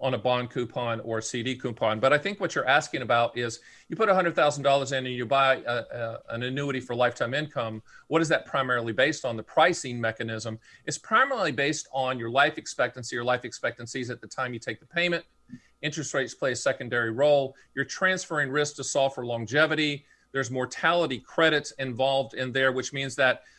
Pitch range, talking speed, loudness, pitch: 120-145 Hz, 205 wpm, -27 LUFS, 130 Hz